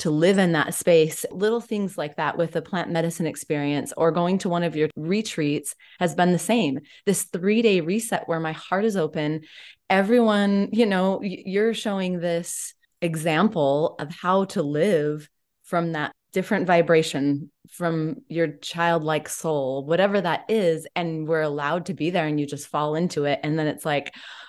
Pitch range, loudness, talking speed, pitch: 155-190 Hz, -23 LUFS, 175 wpm, 170 Hz